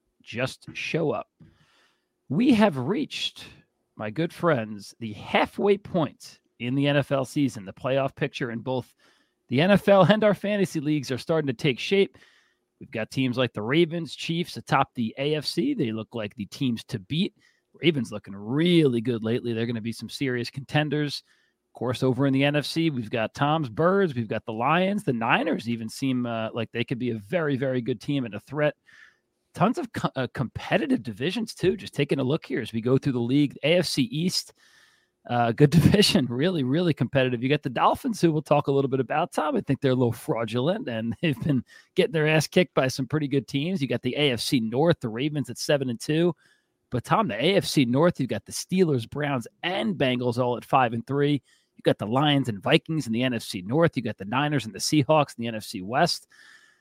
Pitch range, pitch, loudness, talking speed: 120-165 Hz, 140 Hz, -25 LUFS, 210 wpm